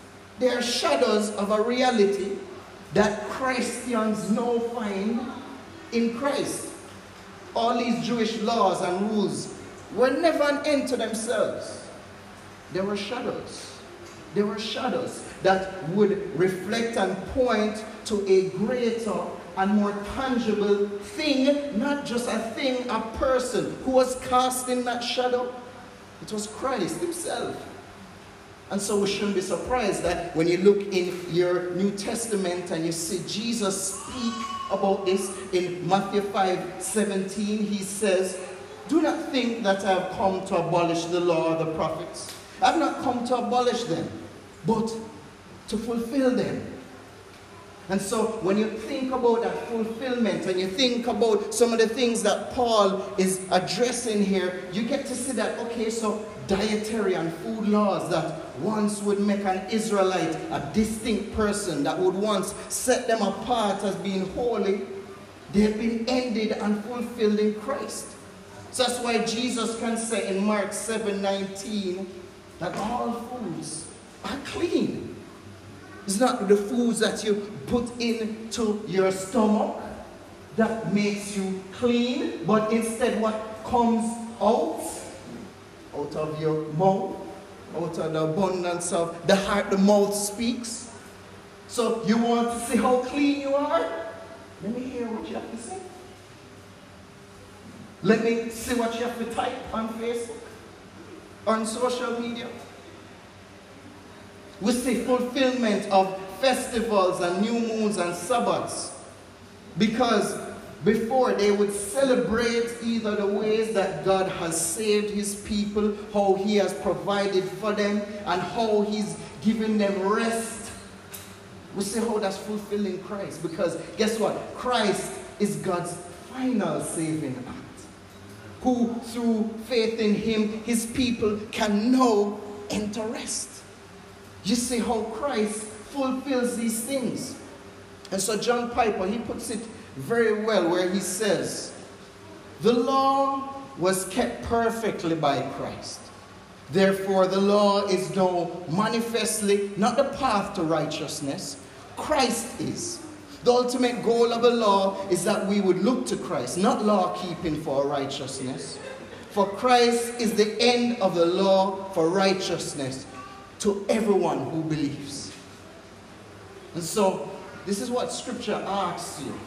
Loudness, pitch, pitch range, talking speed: -26 LUFS, 210 Hz, 190-235 Hz, 135 wpm